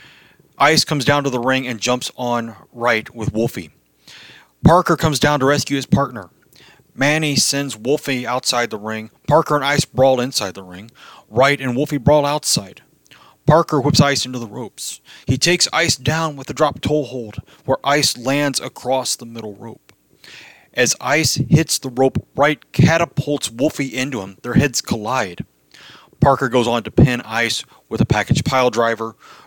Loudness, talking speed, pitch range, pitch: -17 LUFS, 170 wpm, 120-145 Hz, 135 Hz